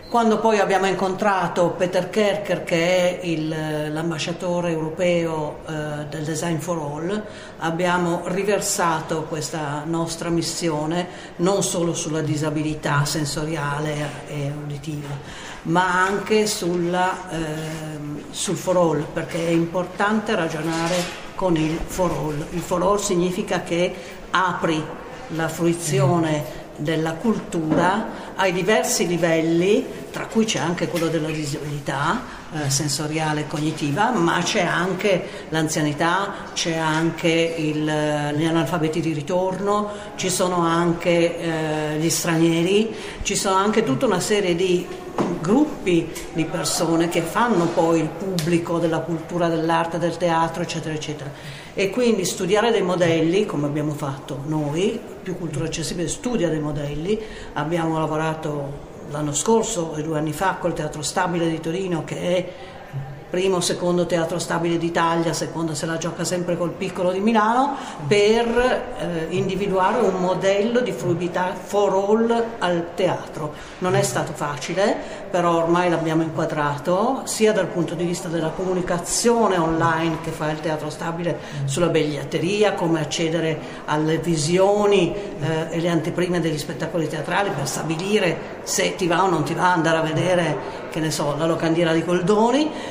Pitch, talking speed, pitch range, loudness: 170 Hz, 140 wpm, 160-185 Hz, -22 LUFS